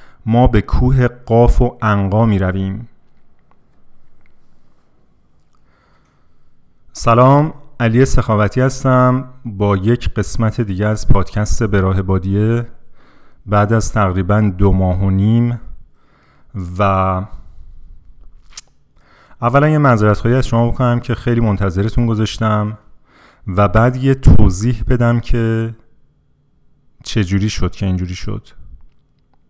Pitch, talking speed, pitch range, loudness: 105 Hz, 100 wpm, 95-120 Hz, -15 LUFS